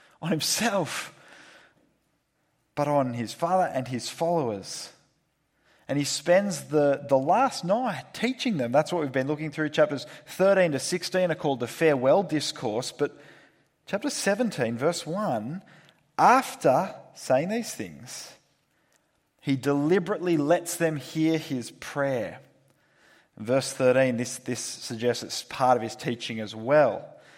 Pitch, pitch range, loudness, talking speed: 150 Hz, 130-180 Hz, -26 LUFS, 135 wpm